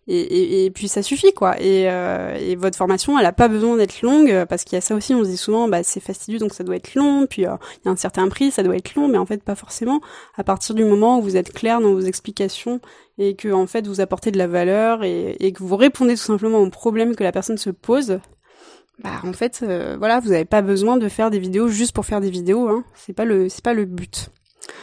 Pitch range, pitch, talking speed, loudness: 190-235 Hz, 210 Hz, 275 wpm, -19 LUFS